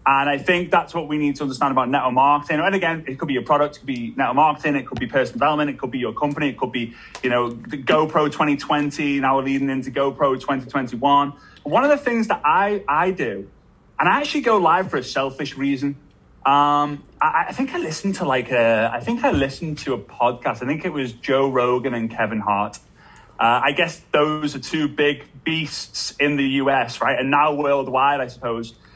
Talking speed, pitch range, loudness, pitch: 220 wpm, 130-155 Hz, -20 LUFS, 145 Hz